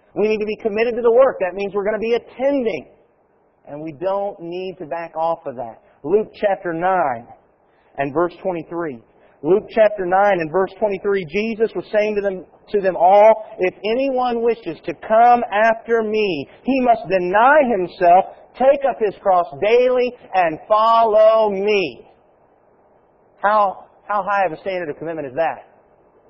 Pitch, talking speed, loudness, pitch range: 205 Hz, 170 wpm, -18 LUFS, 180-225 Hz